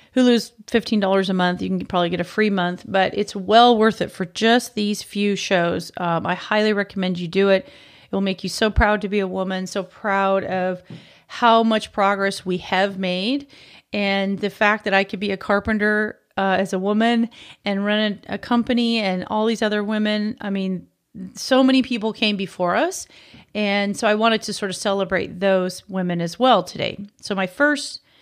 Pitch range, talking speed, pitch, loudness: 190-220 Hz, 200 wpm, 200 Hz, -20 LUFS